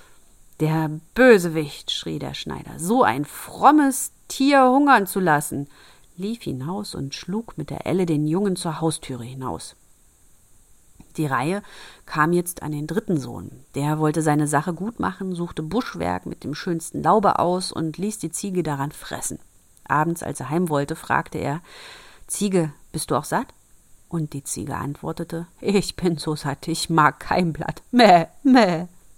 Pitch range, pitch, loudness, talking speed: 150-200 Hz, 165 Hz, -22 LUFS, 160 wpm